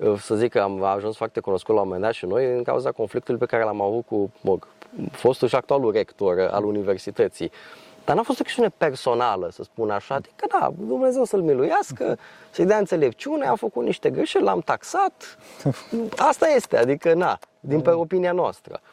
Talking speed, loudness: 185 wpm, -23 LUFS